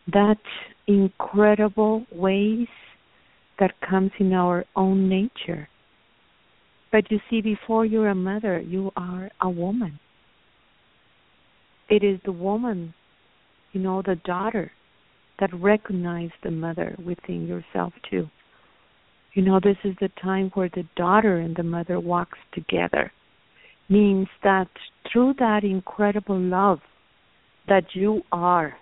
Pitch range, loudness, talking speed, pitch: 180-205 Hz, -23 LUFS, 125 wpm, 195 Hz